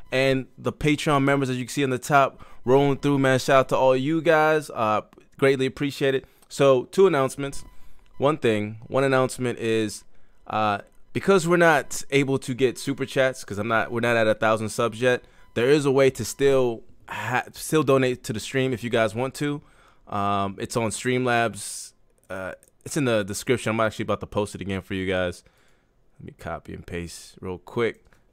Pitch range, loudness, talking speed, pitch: 110-140 Hz, -23 LUFS, 200 wpm, 125 Hz